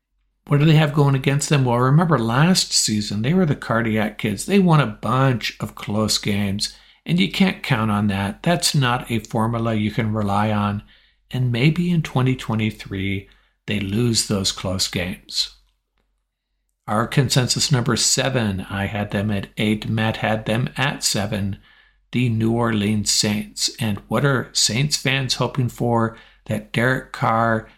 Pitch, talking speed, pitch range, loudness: 115 Hz, 160 wpm, 105-135 Hz, -20 LUFS